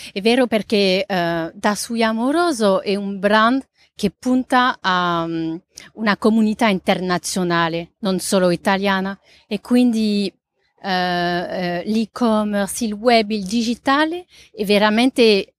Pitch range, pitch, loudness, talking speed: 185-230 Hz, 205 Hz, -18 LUFS, 120 wpm